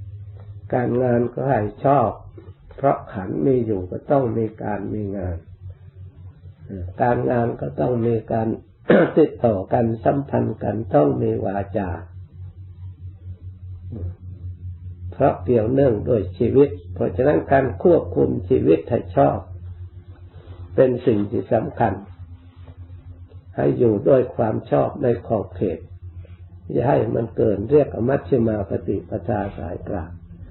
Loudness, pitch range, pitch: -21 LUFS, 90-115 Hz, 95 Hz